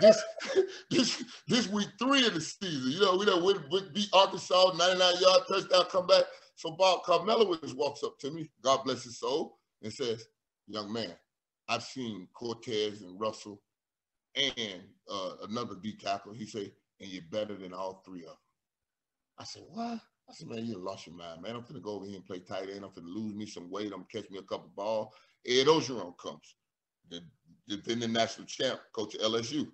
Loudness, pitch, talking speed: -30 LUFS, 130 Hz, 205 wpm